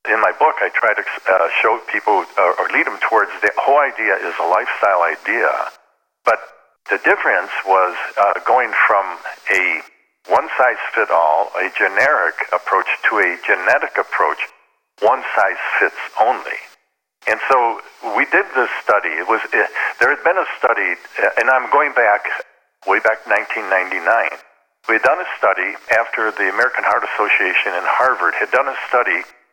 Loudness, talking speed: -16 LUFS, 165 wpm